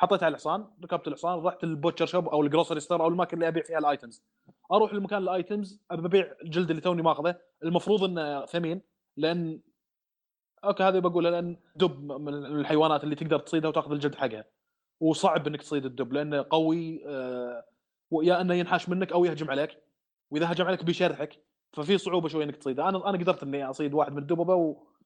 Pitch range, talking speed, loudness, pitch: 150-180 Hz, 175 wpm, -28 LUFS, 165 Hz